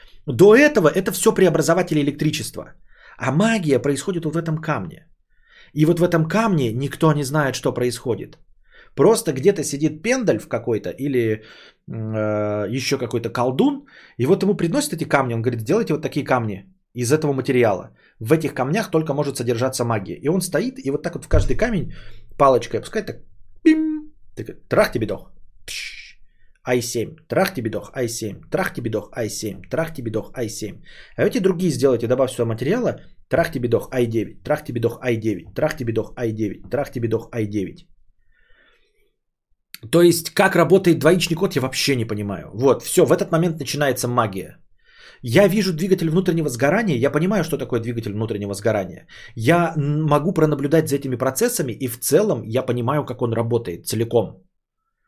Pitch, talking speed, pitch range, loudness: 140 Hz, 160 wpm, 120-170 Hz, -20 LUFS